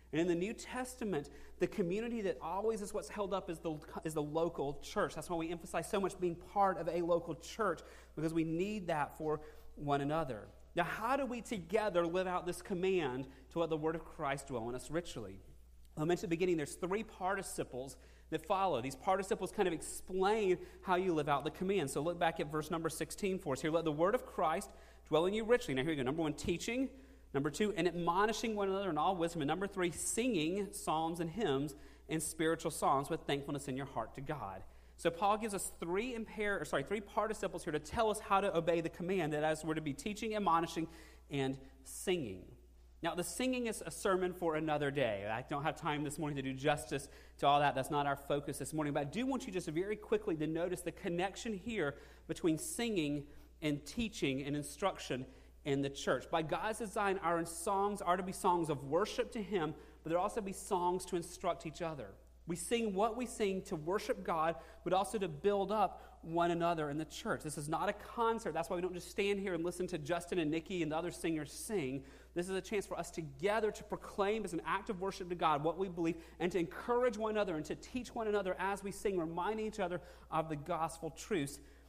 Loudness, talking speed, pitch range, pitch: -38 LUFS, 225 wpm, 155-200 Hz, 175 Hz